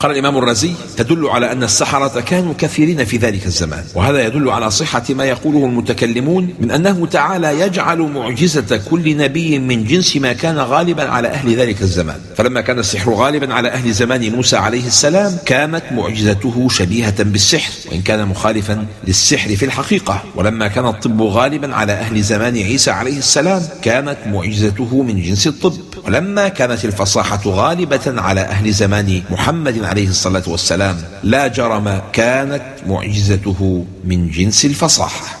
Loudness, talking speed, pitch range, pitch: -14 LUFS, 150 wpm, 105-145 Hz, 120 Hz